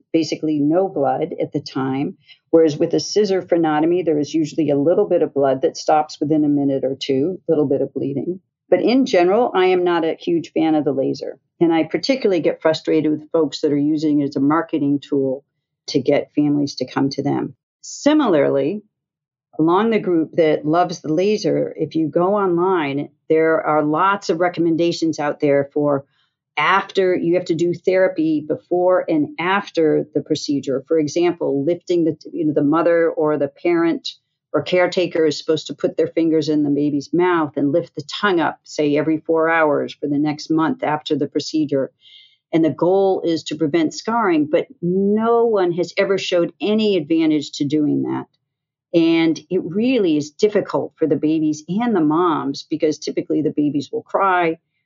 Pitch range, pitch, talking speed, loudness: 145-180 Hz, 160 Hz, 185 wpm, -19 LUFS